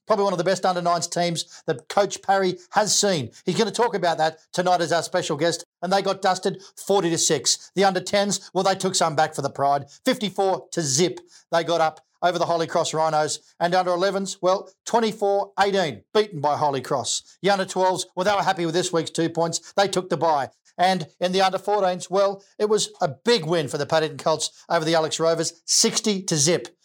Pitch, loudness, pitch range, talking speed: 180 Hz, -22 LUFS, 165-195 Hz, 225 wpm